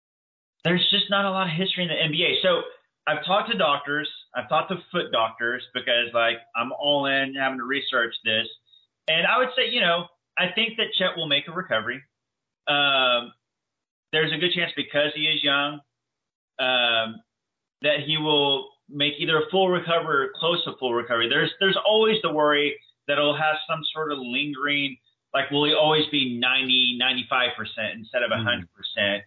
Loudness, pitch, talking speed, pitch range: -23 LUFS, 145 Hz, 185 wpm, 125-165 Hz